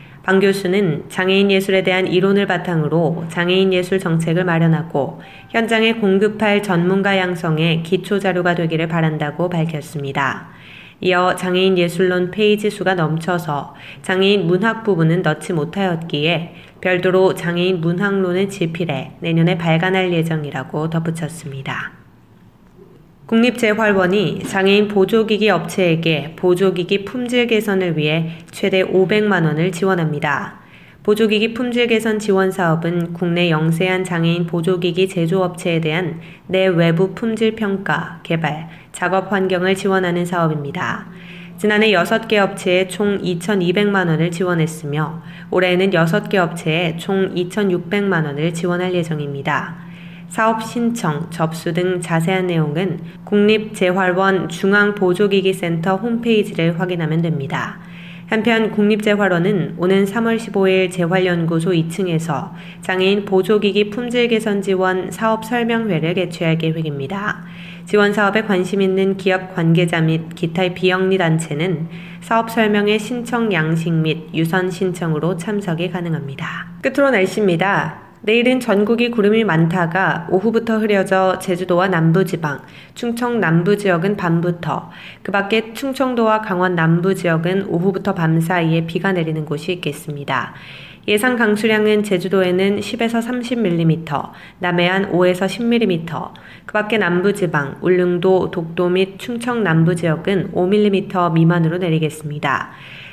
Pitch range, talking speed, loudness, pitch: 170-200 Hz, 300 characters per minute, -17 LUFS, 185 Hz